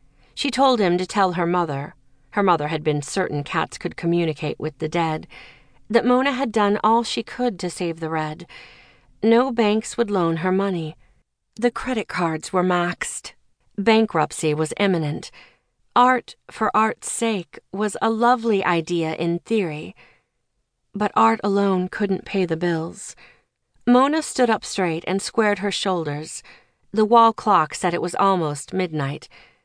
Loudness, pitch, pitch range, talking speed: -21 LUFS, 185 Hz, 165-220 Hz, 155 wpm